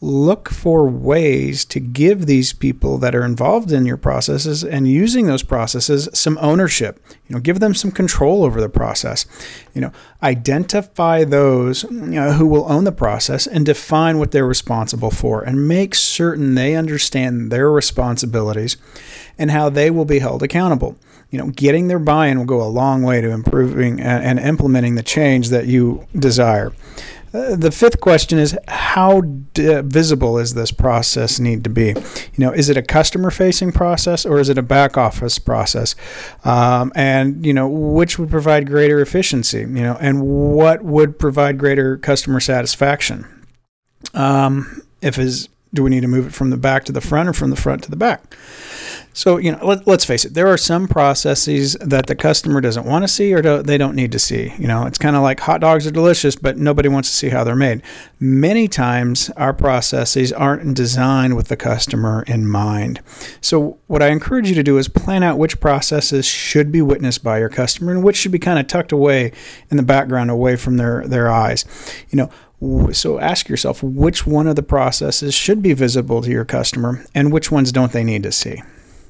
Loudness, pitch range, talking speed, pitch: -15 LUFS, 125-155 Hz, 195 wpm, 140 Hz